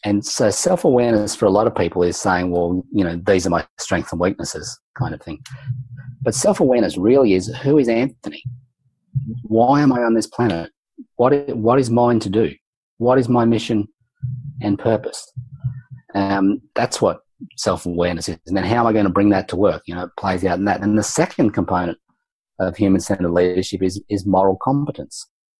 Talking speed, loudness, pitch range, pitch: 200 wpm, -18 LUFS, 95-125 Hz, 110 Hz